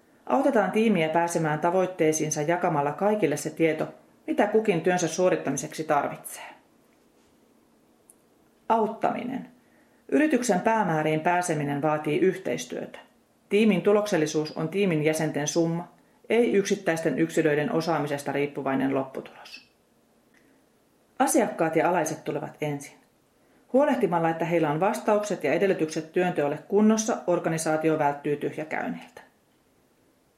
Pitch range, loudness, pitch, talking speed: 155-200 Hz, -25 LUFS, 170 Hz, 95 wpm